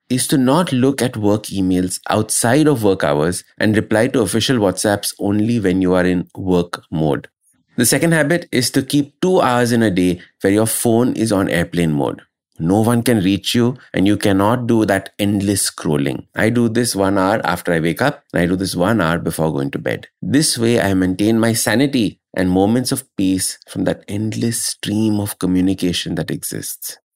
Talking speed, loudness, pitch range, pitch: 200 wpm, -17 LUFS, 95-120 Hz, 105 Hz